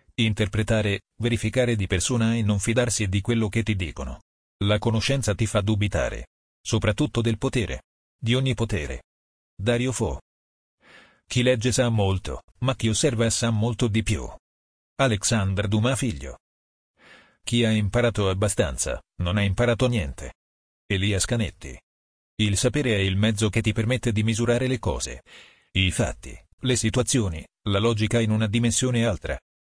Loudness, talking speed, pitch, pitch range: -24 LUFS, 145 wpm, 110 Hz, 90-120 Hz